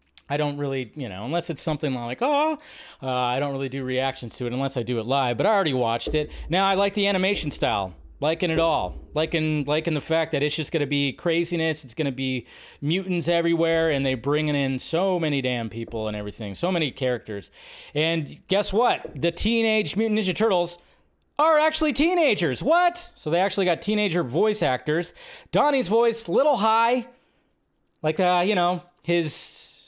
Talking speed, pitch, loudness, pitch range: 190 wpm, 165 Hz, -24 LUFS, 135-200 Hz